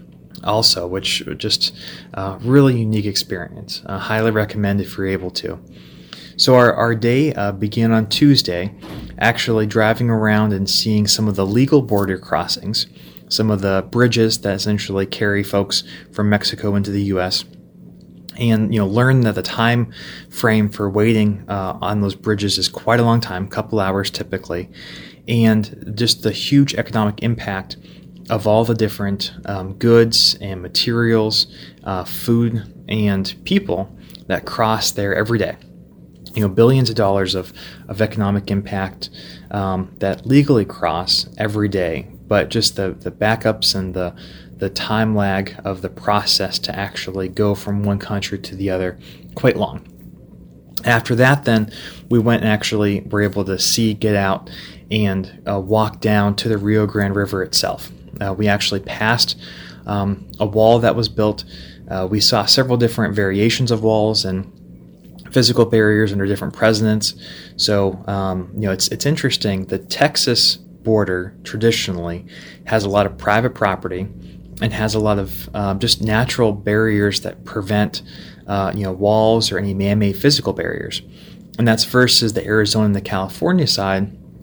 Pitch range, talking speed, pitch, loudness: 95-110 Hz, 160 wpm, 105 Hz, -17 LUFS